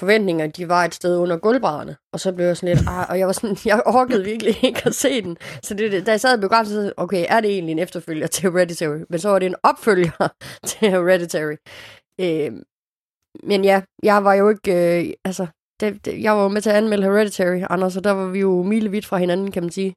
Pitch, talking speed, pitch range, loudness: 195 Hz, 235 wpm, 175-210 Hz, -19 LUFS